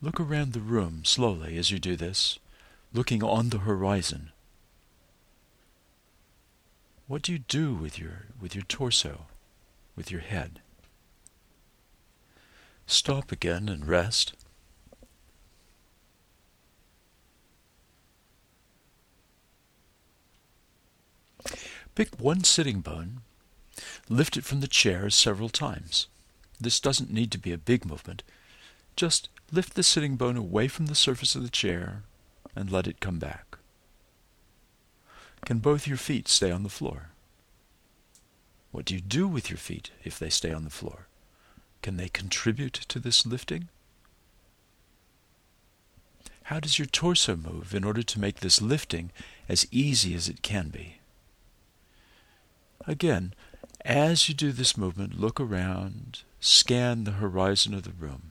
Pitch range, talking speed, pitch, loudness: 90-130 Hz, 125 wpm, 100 Hz, -26 LUFS